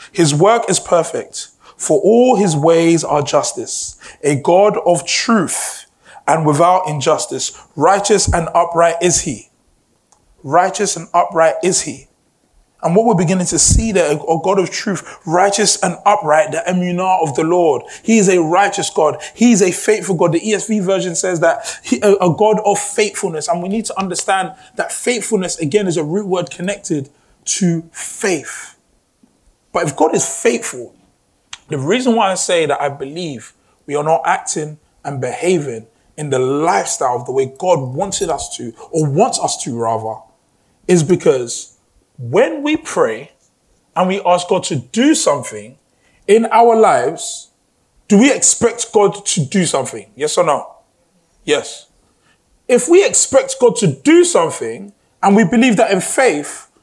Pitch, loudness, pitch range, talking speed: 185 Hz, -15 LUFS, 160-210 Hz, 160 wpm